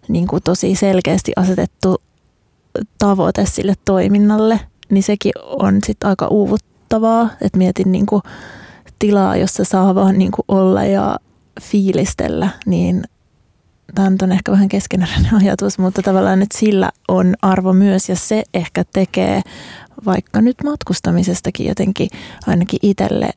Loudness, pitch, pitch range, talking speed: -15 LUFS, 195 Hz, 185-205 Hz, 130 wpm